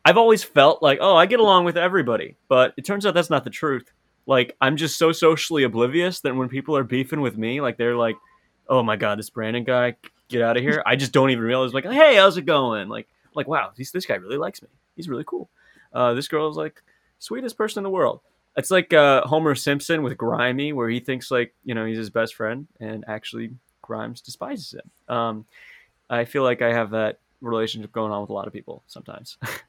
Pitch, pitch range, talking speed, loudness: 130 Hz, 115-160 Hz, 230 wpm, -21 LUFS